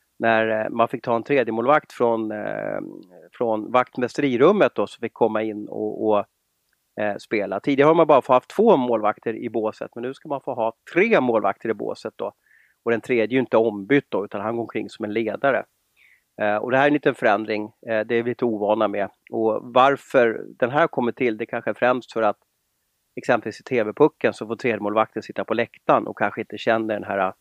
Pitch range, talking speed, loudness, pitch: 110-125 Hz, 210 wpm, -22 LUFS, 115 Hz